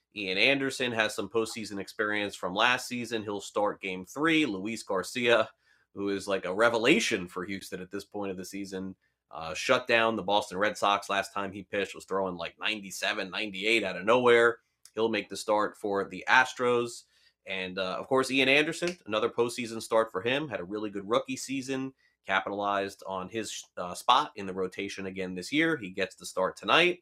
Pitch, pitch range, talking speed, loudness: 105 Hz, 95-120 Hz, 195 wpm, -29 LUFS